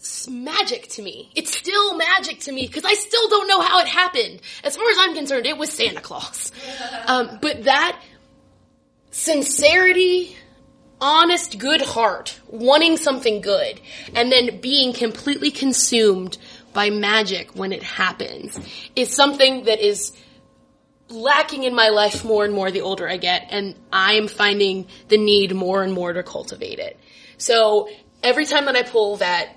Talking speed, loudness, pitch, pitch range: 160 wpm, -18 LUFS, 260 Hz, 210-310 Hz